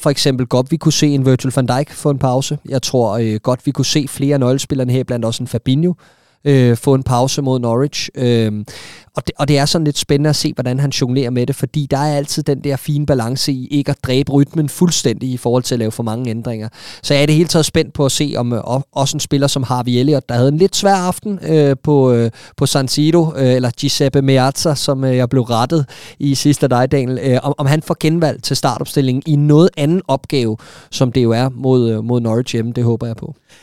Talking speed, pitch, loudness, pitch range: 250 wpm, 135 Hz, -15 LUFS, 125-150 Hz